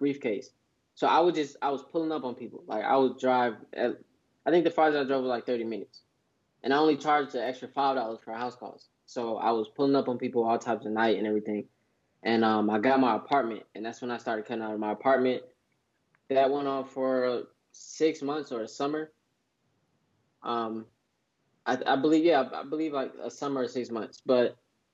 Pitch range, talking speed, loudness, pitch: 115-140 Hz, 215 wpm, -29 LUFS, 130 Hz